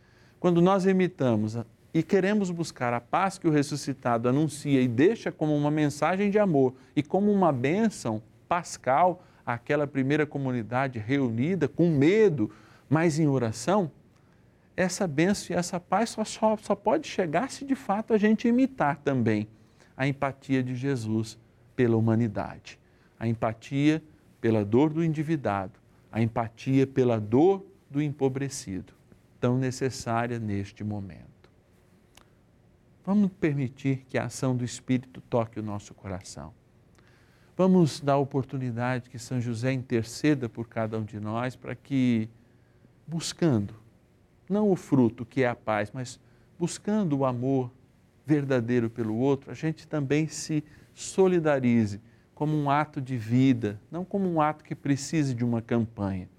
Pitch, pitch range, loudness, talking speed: 135 Hz, 115-160 Hz, -27 LUFS, 140 wpm